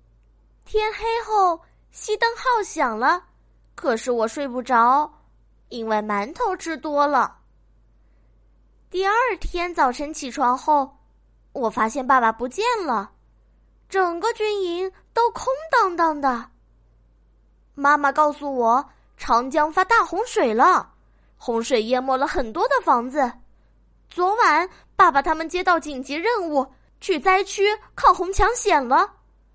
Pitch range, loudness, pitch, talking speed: 265-410 Hz, -21 LUFS, 320 Hz, 180 characters per minute